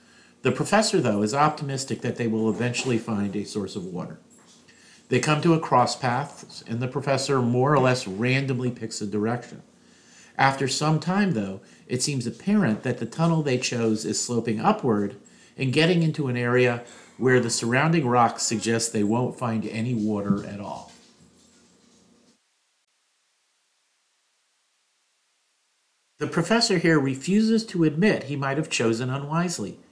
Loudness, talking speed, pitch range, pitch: -24 LUFS, 145 wpm, 115-150 Hz, 125 Hz